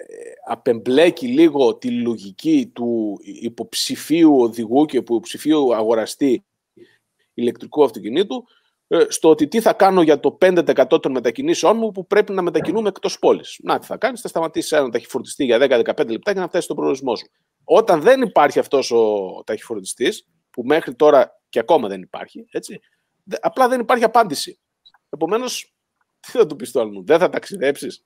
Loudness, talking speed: -18 LUFS, 150 wpm